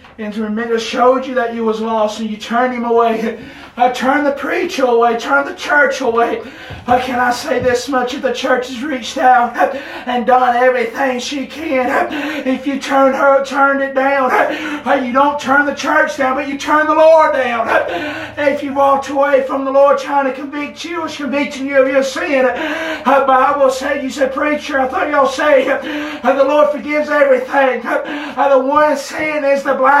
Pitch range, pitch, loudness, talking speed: 250-290 Hz, 270 Hz, -14 LUFS, 215 wpm